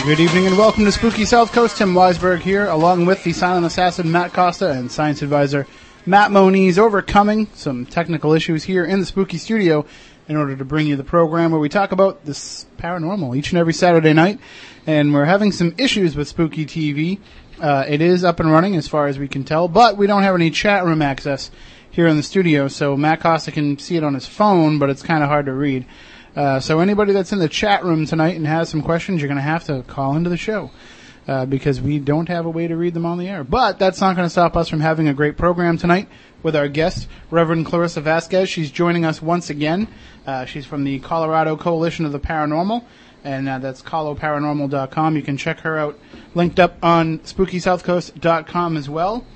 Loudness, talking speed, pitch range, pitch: -17 LUFS, 220 wpm, 150-180 Hz, 165 Hz